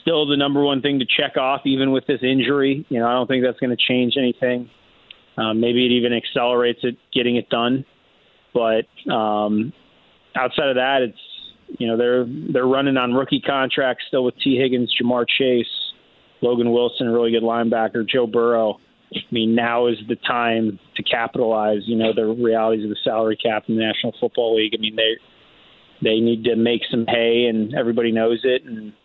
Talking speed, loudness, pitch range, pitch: 195 wpm, -19 LUFS, 115-130 Hz, 120 Hz